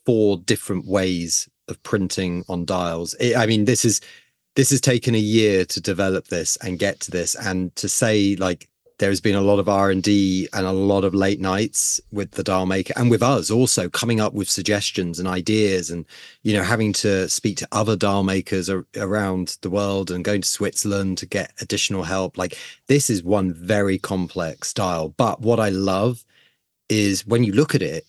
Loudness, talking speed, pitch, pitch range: -21 LUFS, 205 wpm, 100 Hz, 95-110 Hz